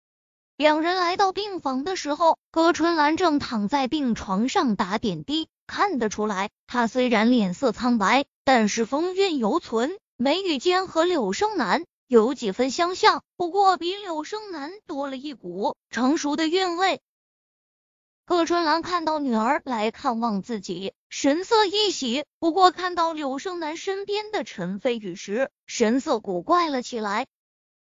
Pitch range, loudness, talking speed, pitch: 235-350 Hz, -24 LUFS, 220 characters per minute, 290 Hz